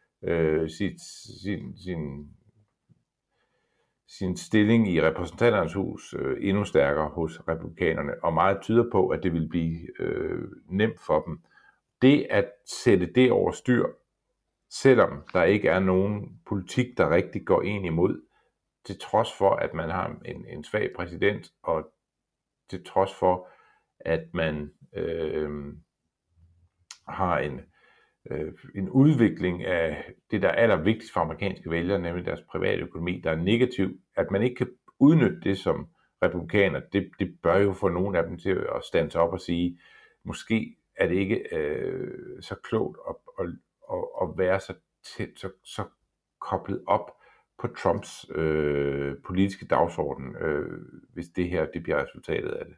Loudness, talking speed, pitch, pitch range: -26 LUFS, 150 wpm, 90 Hz, 80-105 Hz